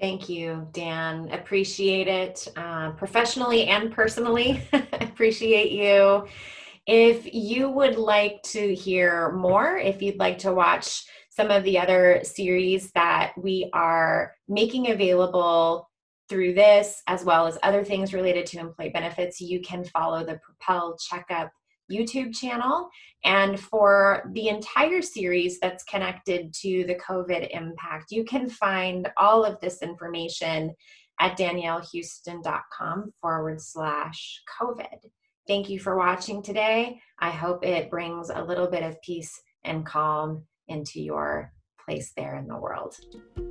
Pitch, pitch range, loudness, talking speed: 185 Hz, 170-205 Hz, -24 LUFS, 135 wpm